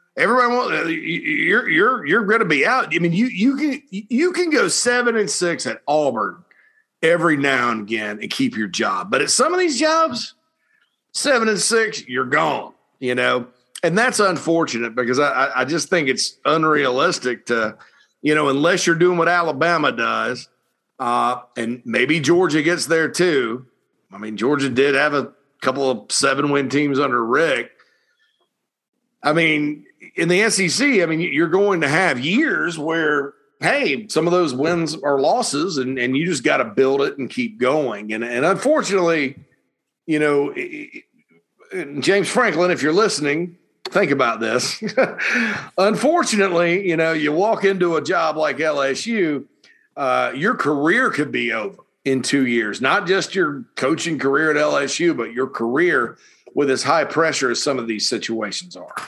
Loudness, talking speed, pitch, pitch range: -19 LUFS, 165 wpm, 165 Hz, 140-220 Hz